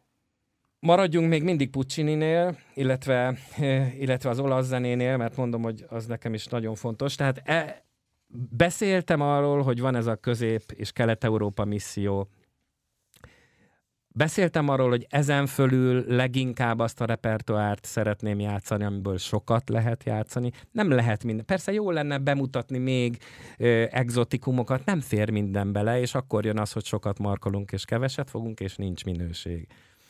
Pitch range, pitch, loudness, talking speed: 110-135 Hz, 120 Hz, -26 LUFS, 140 wpm